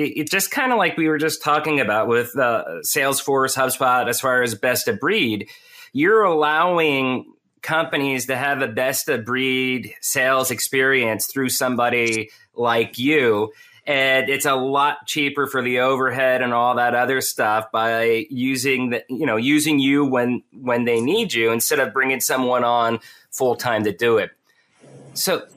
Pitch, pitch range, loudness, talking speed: 130 Hz, 120-145 Hz, -19 LUFS, 165 wpm